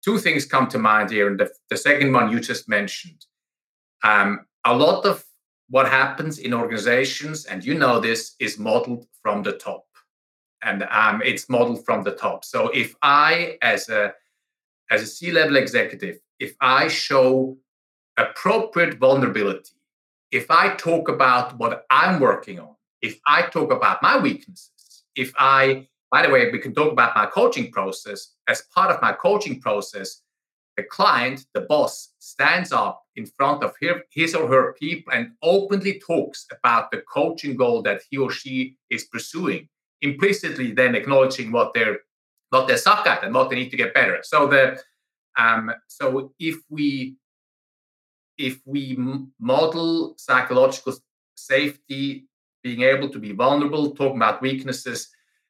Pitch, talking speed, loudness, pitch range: 140 Hz, 155 wpm, -20 LUFS, 130-175 Hz